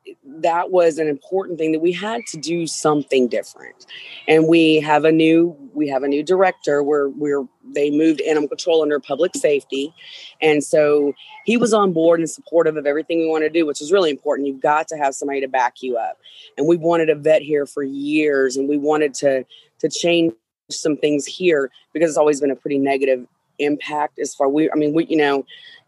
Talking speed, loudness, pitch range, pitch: 210 wpm, -18 LUFS, 145-170 Hz, 155 Hz